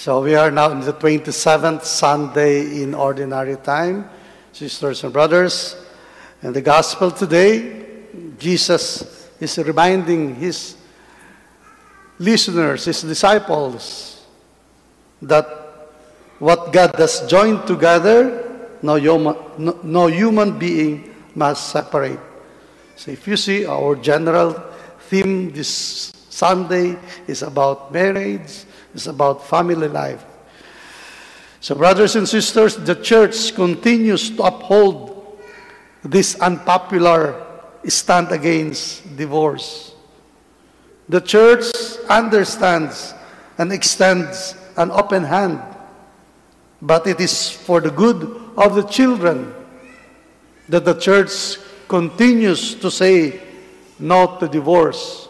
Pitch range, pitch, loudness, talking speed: 155-200 Hz, 175 Hz, -16 LUFS, 100 wpm